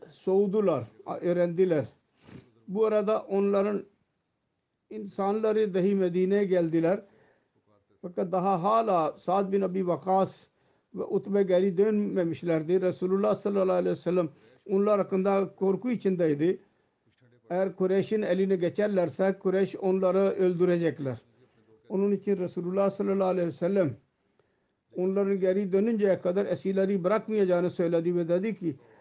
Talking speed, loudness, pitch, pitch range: 110 wpm, -27 LUFS, 190 Hz, 175-200 Hz